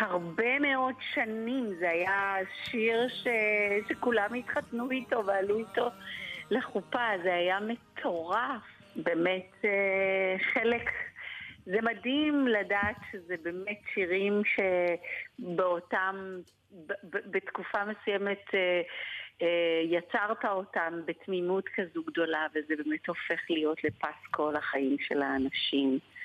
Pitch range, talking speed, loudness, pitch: 175-230 Hz, 100 wpm, -31 LUFS, 195 Hz